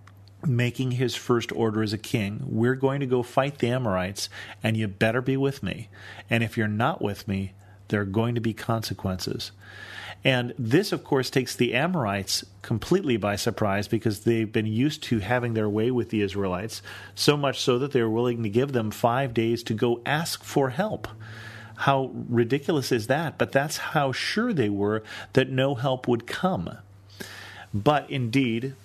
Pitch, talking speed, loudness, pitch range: 115 Hz, 180 wpm, -26 LUFS, 105-130 Hz